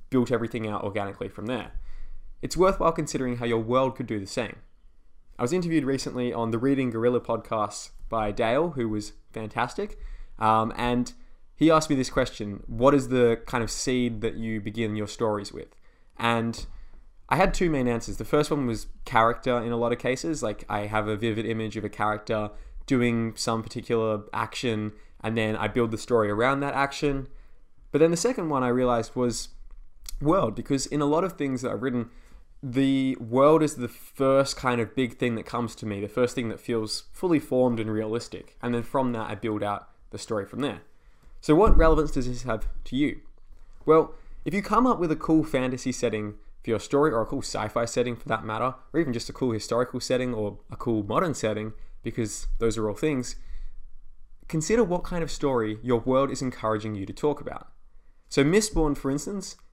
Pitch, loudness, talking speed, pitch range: 120 Hz, -26 LUFS, 205 wpm, 110-135 Hz